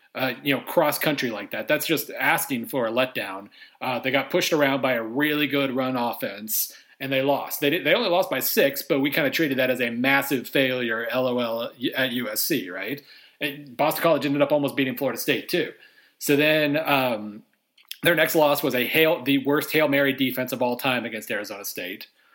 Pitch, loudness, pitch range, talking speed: 140 Hz, -23 LUFS, 130-150 Hz, 210 wpm